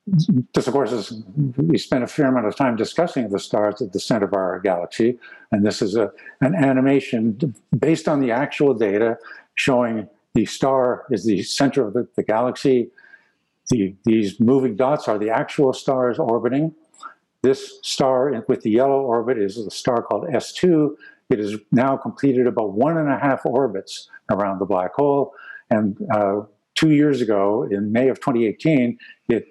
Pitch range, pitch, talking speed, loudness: 110-140 Hz, 125 Hz, 175 wpm, -20 LUFS